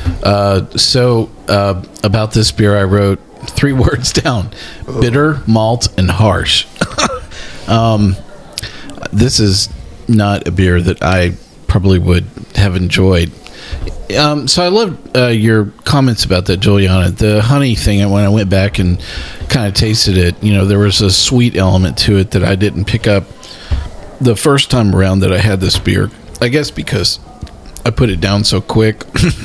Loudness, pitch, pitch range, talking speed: -12 LUFS, 100 Hz, 95-115 Hz, 165 wpm